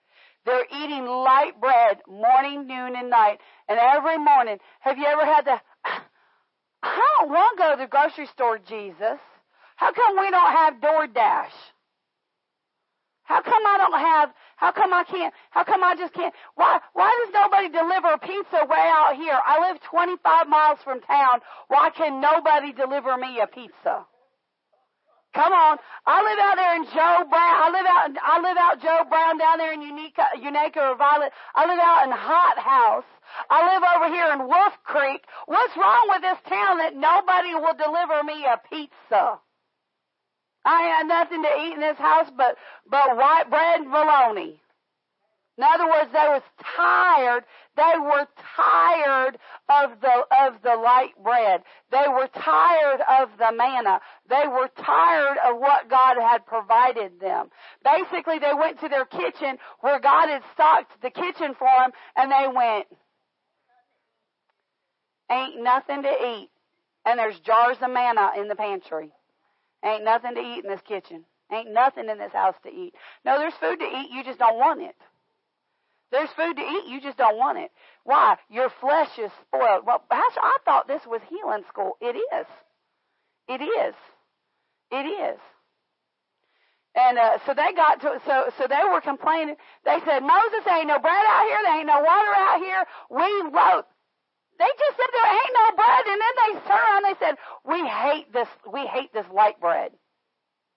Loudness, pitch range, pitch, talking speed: -21 LUFS, 255-340 Hz, 295 Hz, 175 wpm